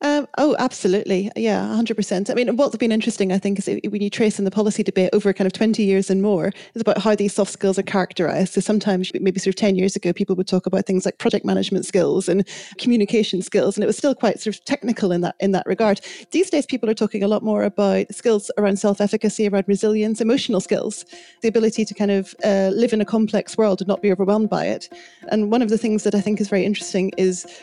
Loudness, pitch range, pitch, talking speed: -20 LUFS, 195-220 Hz, 205 Hz, 250 wpm